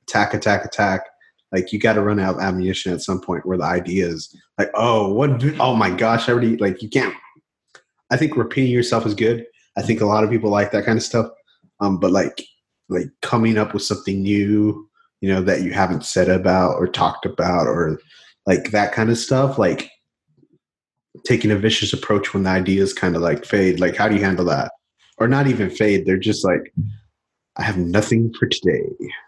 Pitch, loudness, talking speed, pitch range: 105 Hz, -19 LUFS, 205 wpm, 95-115 Hz